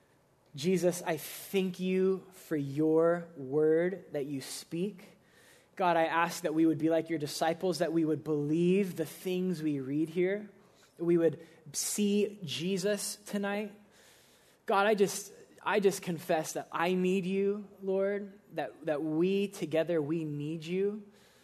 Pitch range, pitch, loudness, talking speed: 160-195 Hz, 175 Hz, -32 LUFS, 150 wpm